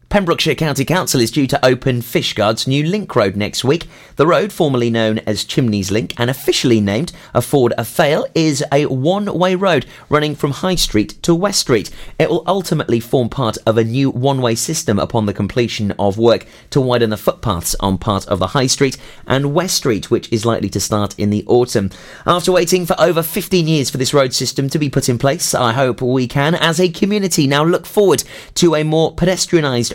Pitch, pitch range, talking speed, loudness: 135 Hz, 115-165 Hz, 205 wpm, -15 LUFS